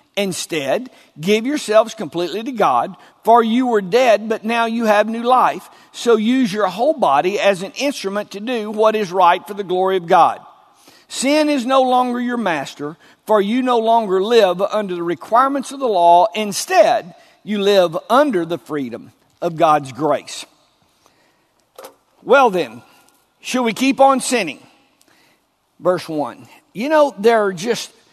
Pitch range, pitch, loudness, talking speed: 190-250 Hz, 220 Hz, -16 LUFS, 160 wpm